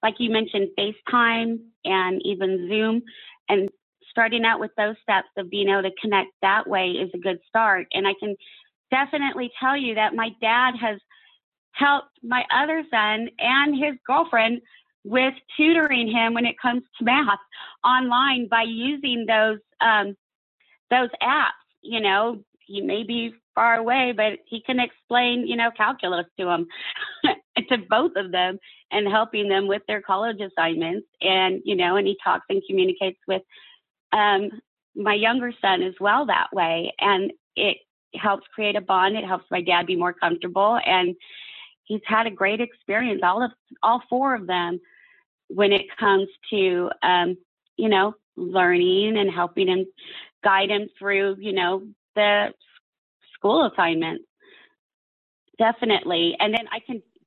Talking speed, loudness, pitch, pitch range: 155 wpm, -22 LUFS, 215 Hz, 195-245 Hz